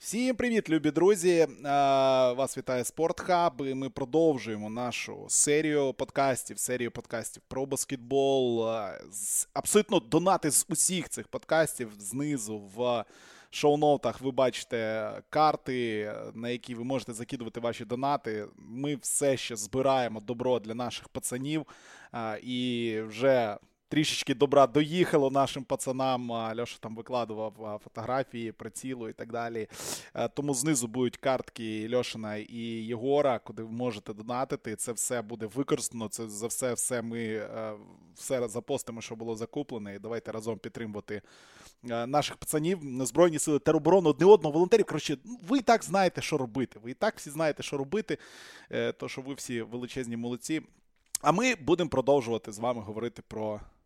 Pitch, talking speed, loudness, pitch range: 125 Hz, 135 wpm, -29 LUFS, 115-145 Hz